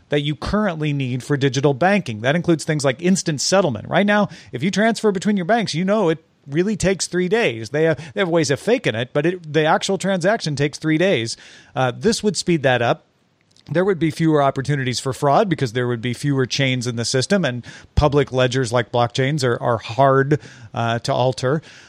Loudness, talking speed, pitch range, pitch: -19 LUFS, 210 wpm, 130-180 Hz, 150 Hz